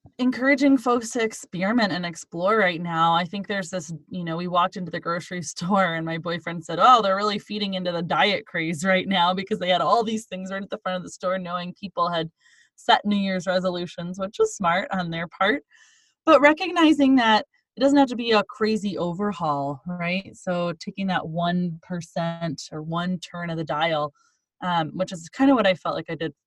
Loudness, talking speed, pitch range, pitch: -23 LUFS, 210 wpm, 170-205 Hz, 185 Hz